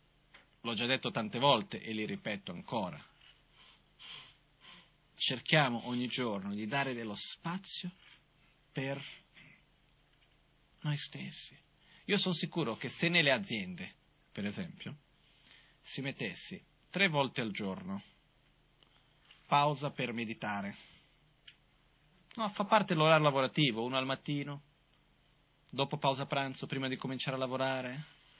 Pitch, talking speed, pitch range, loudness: 145 Hz, 110 wpm, 130-155 Hz, -34 LUFS